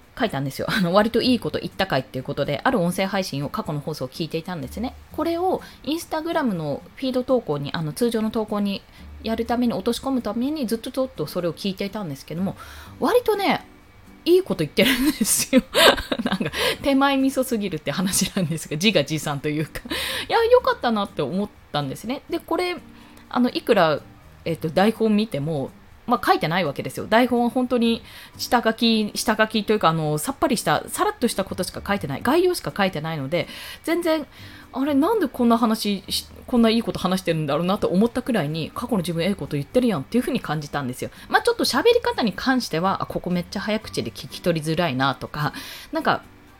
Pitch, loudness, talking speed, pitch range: 215 Hz, -23 LUFS, 440 characters per minute, 170-255 Hz